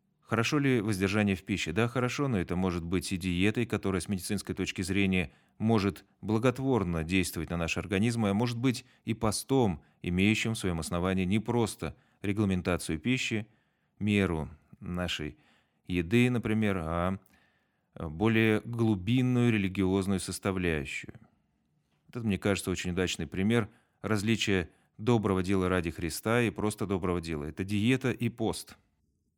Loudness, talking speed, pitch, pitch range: -30 LUFS, 135 wpm, 100 Hz, 90-115 Hz